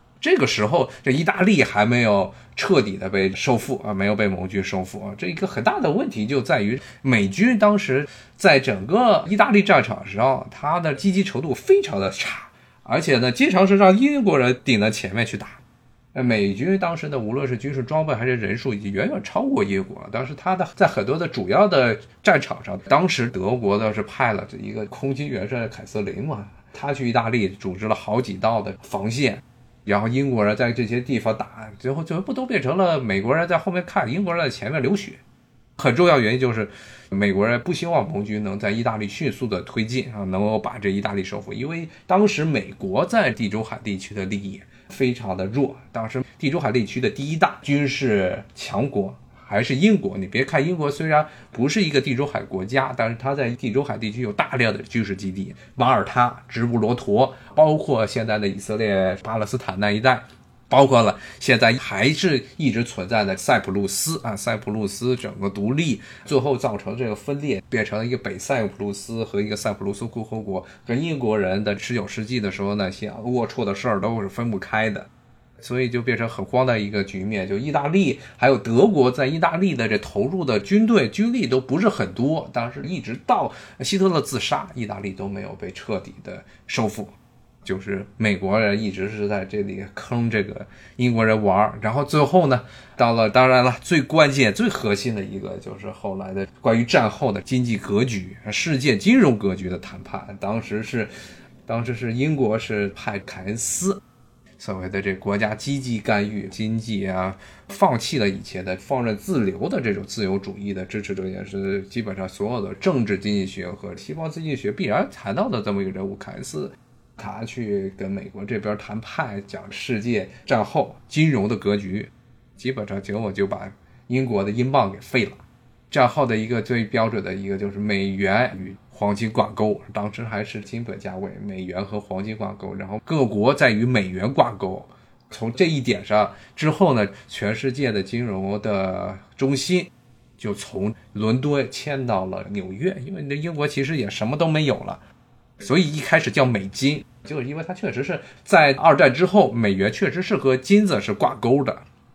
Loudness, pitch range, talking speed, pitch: -22 LUFS, 105-135 Hz, 290 characters per minute, 115 Hz